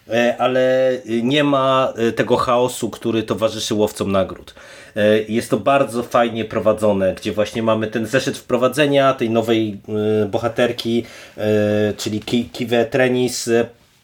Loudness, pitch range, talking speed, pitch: -18 LUFS, 110-125 Hz, 115 wpm, 115 Hz